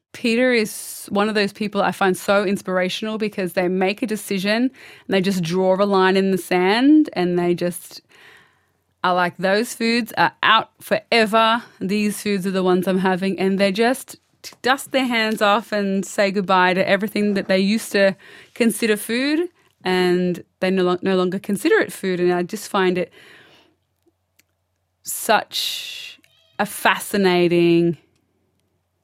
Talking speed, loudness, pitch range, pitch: 155 wpm, -19 LUFS, 180-215 Hz, 195 Hz